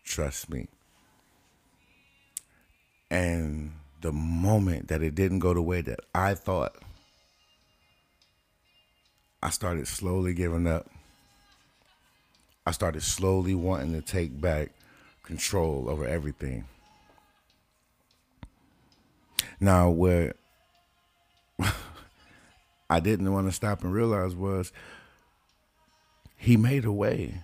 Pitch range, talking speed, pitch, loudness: 80-95 Hz, 95 wpm, 90 Hz, -28 LUFS